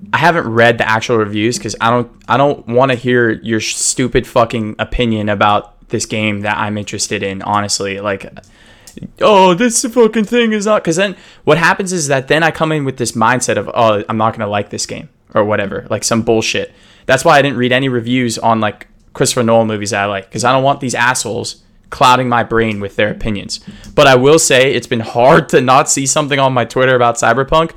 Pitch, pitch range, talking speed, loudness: 120 Hz, 110-140 Hz, 220 wpm, -13 LUFS